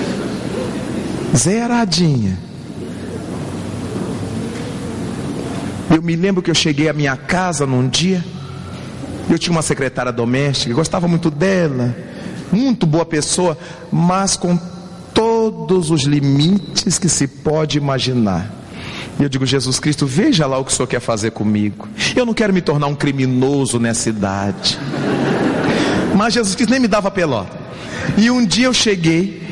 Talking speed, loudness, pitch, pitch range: 140 wpm, -16 LUFS, 160 Hz, 130-185 Hz